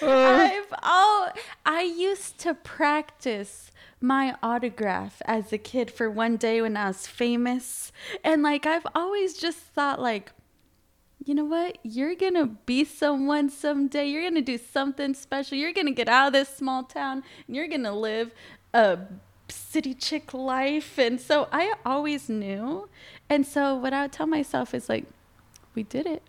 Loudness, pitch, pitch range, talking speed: -26 LUFS, 275 Hz, 240-305 Hz, 170 wpm